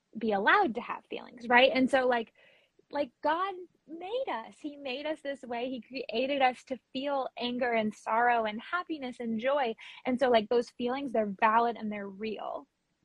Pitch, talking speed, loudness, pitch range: 250 Hz, 185 wpm, -30 LUFS, 230-275 Hz